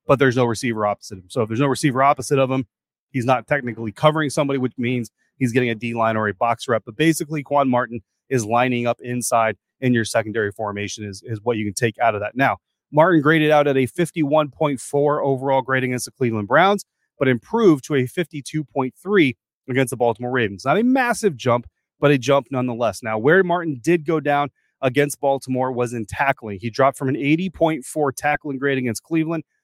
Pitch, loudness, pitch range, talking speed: 130 Hz, -20 LUFS, 120-145 Hz, 200 wpm